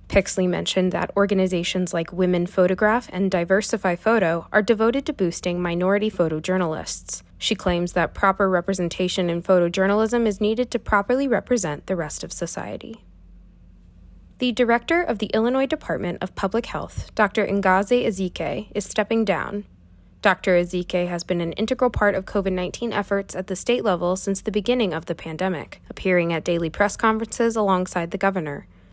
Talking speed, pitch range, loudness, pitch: 155 wpm, 175-215 Hz, -22 LUFS, 190 Hz